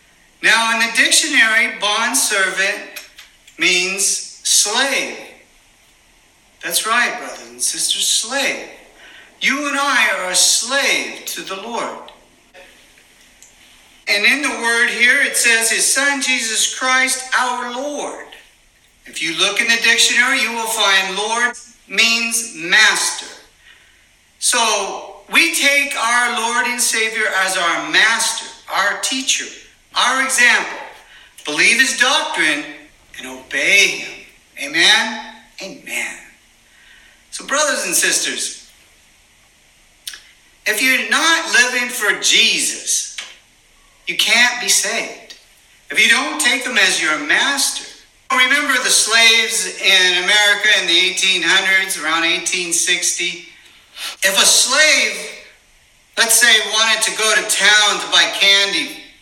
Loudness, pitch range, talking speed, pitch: -14 LUFS, 190-255 Hz, 115 wpm, 225 Hz